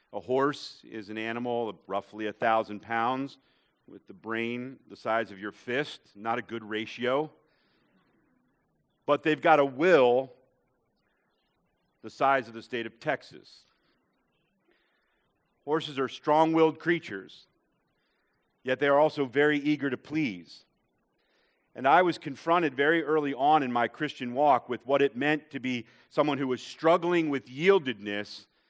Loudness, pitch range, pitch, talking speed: -28 LUFS, 115-150 Hz, 130 Hz, 145 wpm